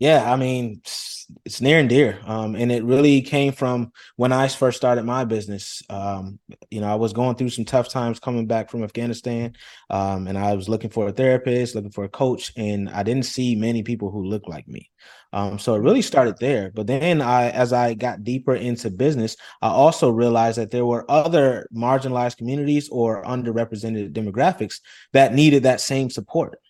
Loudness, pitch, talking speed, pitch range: -21 LUFS, 120 Hz, 195 wpm, 110-130 Hz